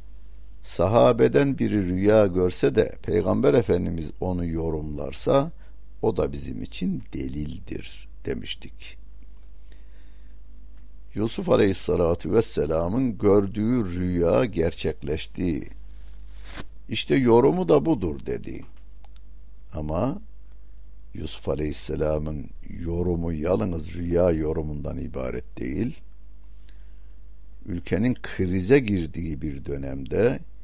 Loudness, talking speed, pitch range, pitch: -24 LUFS, 80 wpm, 75-100 Hz, 85 Hz